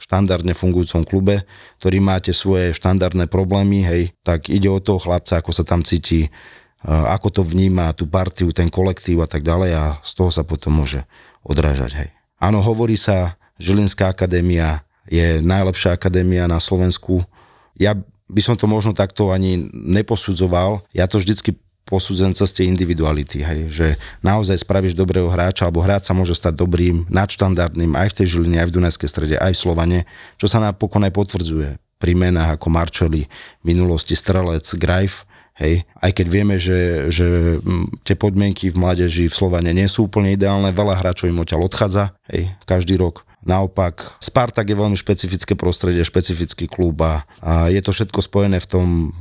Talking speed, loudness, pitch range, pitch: 165 wpm, -17 LUFS, 85-100 Hz, 90 Hz